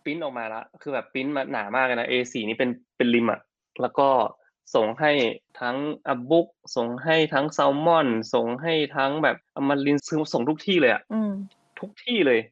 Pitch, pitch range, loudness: 140 Hz, 125-160 Hz, -24 LUFS